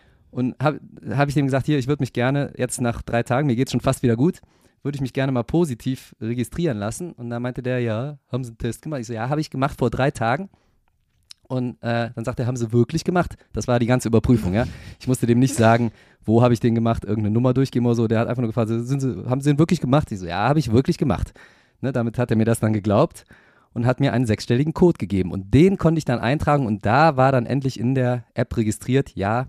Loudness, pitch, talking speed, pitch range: -21 LUFS, 125 Hz, 265 wpm, 115-140 Hz